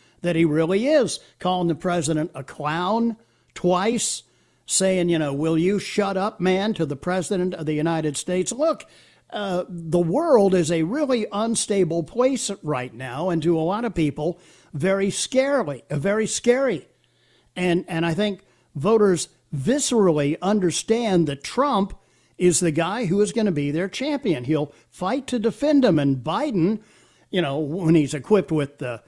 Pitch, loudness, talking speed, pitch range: 180 Hz, -22 LUFS, 165 wpm, 160-210 Hz